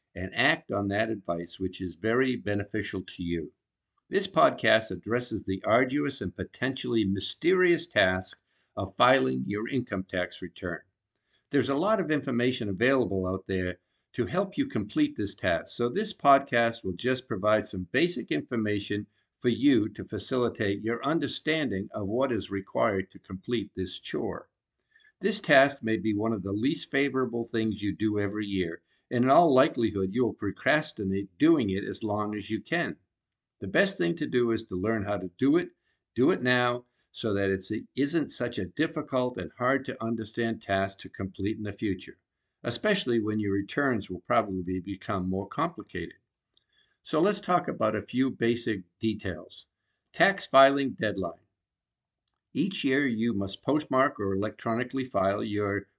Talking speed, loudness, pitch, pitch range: 165 wpm, -28 LUFS, 110 Hz, 95-130 Hz